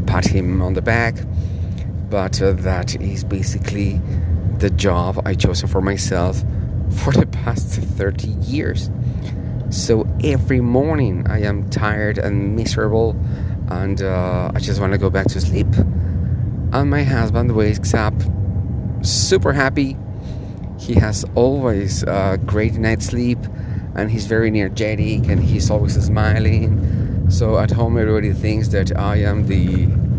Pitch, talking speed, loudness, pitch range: 105 Hz, 135 wpm, -18 LUFS, 95-110 Hz